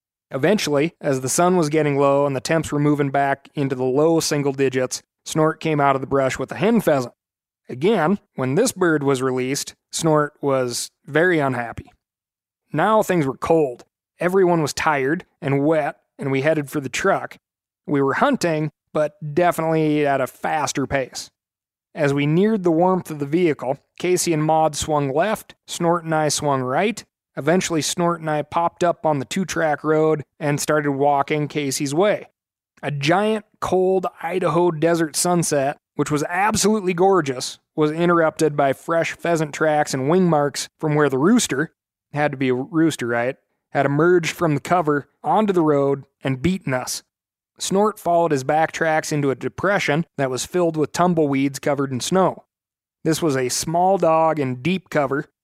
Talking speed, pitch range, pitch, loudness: 175 wpm, 140-170 Hz, 155 Hz, -20 LUFS